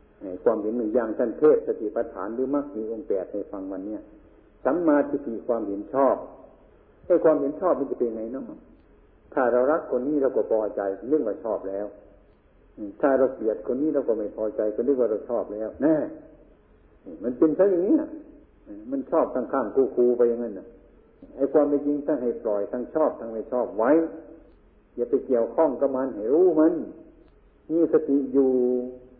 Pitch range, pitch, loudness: 110-170 Hz, 135 Hz, -25 LUFS